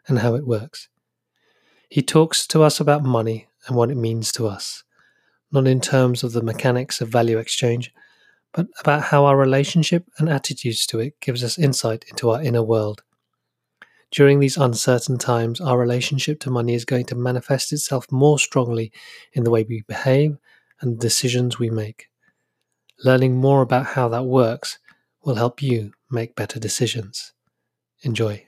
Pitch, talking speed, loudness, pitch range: 125 Hz, 165 wpm, -20 LUFS, 115-140 Hz